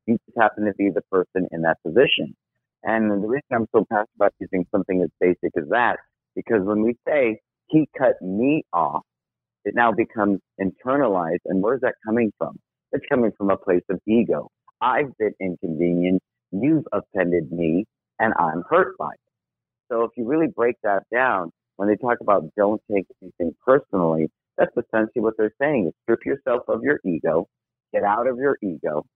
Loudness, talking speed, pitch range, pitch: -22 LUFS, 185 wpm, 90-115 Hz, 100 Hz